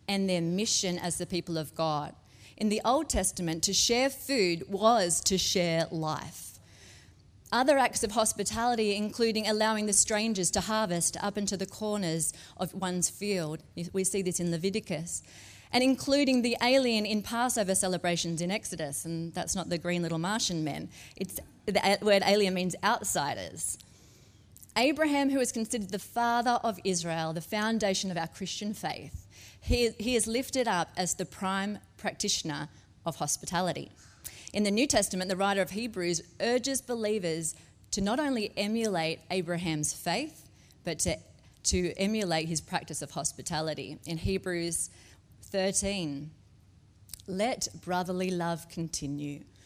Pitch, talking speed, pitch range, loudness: 185 Hz, 145 wpm, 165-215 Hz, -30 LUFS